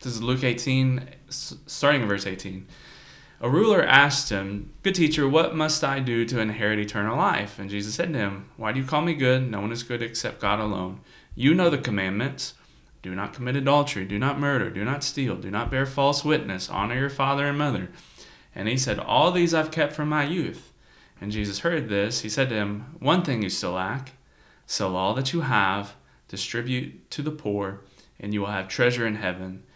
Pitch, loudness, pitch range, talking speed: 120 Hz, -25 LUFS, 100-140 Hz, 210 wpm